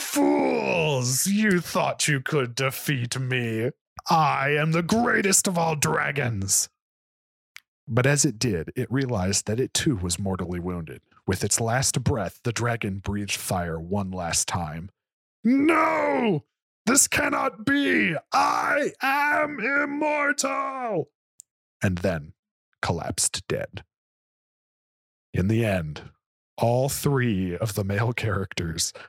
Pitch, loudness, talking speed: 125 Hz, -24 LUFS, 120 wpm